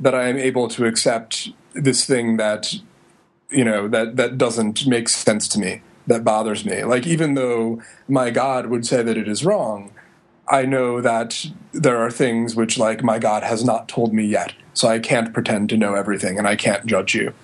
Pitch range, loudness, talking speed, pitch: 110-125 Hz, -19 LUFS, 205 wpm, 115 Hz